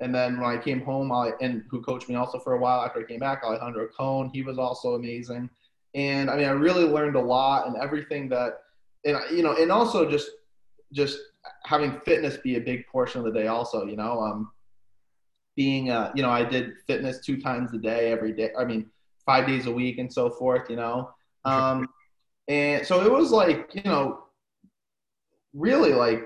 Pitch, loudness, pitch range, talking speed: 125 Hz, -26 LUFS, 120-135 Hz, 205 wpm